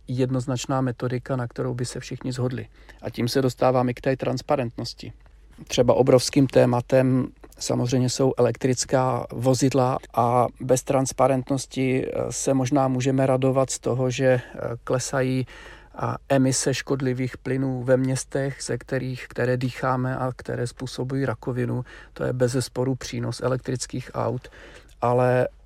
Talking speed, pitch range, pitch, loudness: 125 wpm, 125-130 Hz, 130 Hz, -24 LUFS